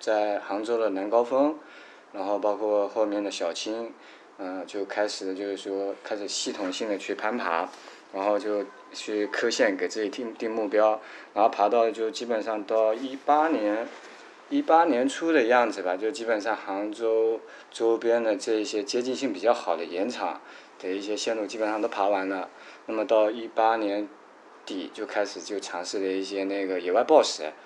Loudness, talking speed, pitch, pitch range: -27 LUFS, 265 characters per minute, 105 Hz, 100-115 Hz